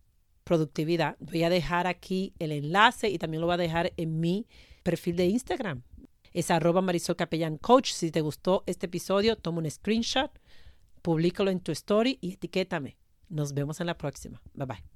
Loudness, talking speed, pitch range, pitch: -28 LUFS, 175 wpm, 160-185 Hz, 175 Hz